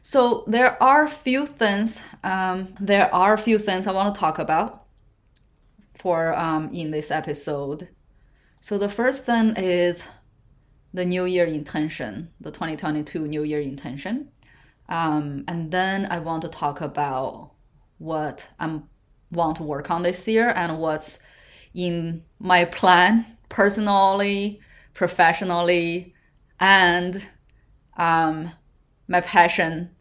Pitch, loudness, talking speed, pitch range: 175 Hz, -22 LUFS, 125 wpm, 155-200 Hz